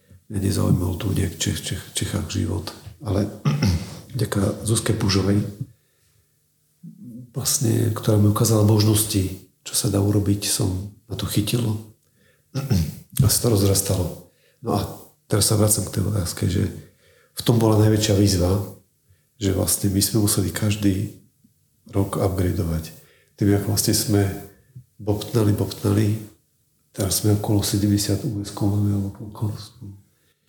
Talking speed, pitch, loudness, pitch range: 125 wpm, 105 Hz, -22 LUFS, 100-110 Hz